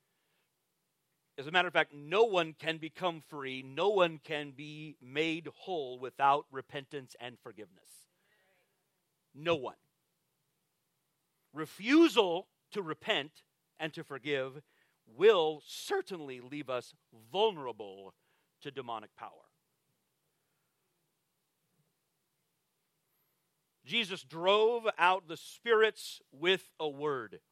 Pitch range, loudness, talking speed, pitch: 145-180 Hz, -32 LUFS, 95 wpm, 160 Hz